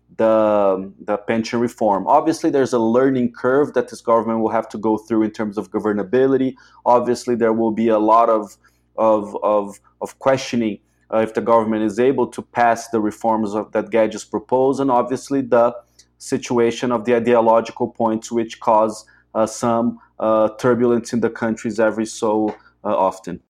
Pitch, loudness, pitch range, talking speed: 115 Hz, -19 LUFS, 110-120 Hz, 170 wpm